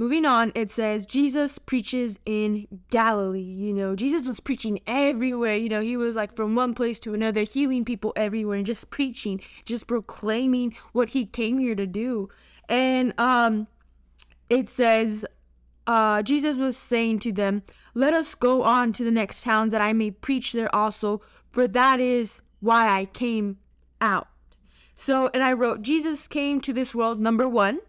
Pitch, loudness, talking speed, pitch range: 230 Hz, -24 LUFS, 170 wpm, 215-255 Hz